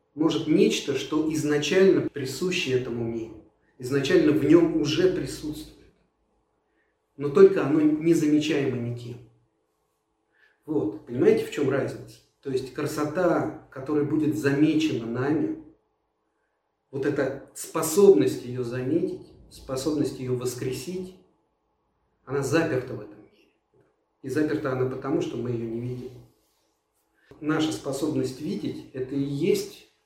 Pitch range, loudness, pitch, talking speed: 125-160 Hz, -25 LUFS, 145 Hz, 115 wpm